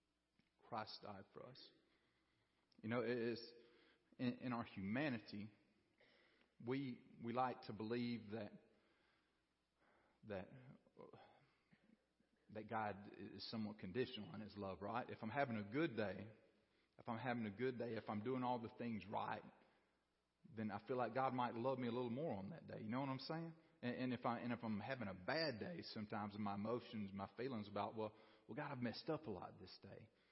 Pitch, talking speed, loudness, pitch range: 115 Hz, 185 wpm, -48 LUFS, 105-125 Hz